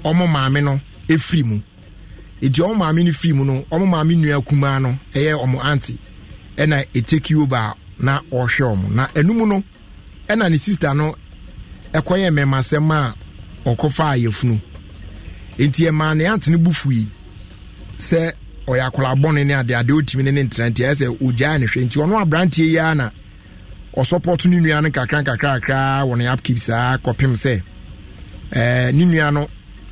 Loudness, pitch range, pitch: -17 LUFS, 110-155 Hz, 135 Hz